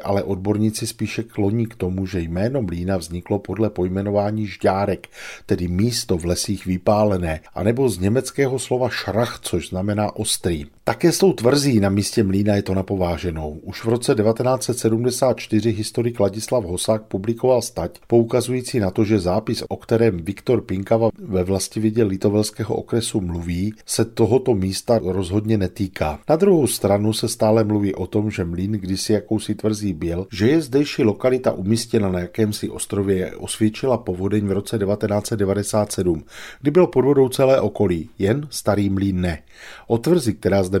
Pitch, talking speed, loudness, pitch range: 105 Hz, 155 wpm, -20 LUFS, 95-115 Hz